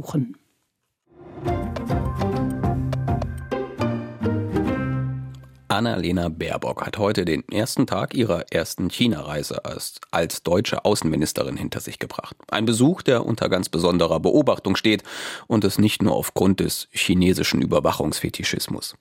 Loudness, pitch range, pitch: -23 LUFS, 90-120 Hz, 105 Hz